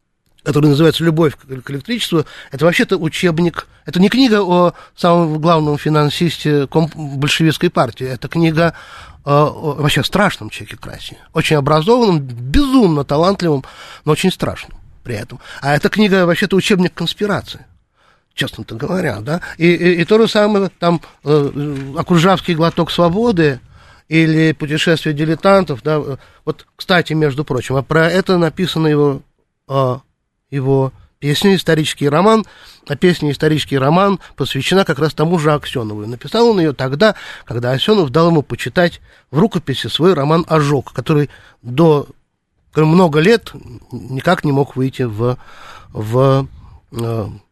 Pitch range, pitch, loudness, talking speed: 135-175 Hz, 155 Hz, -15 LUFS, 135 wpm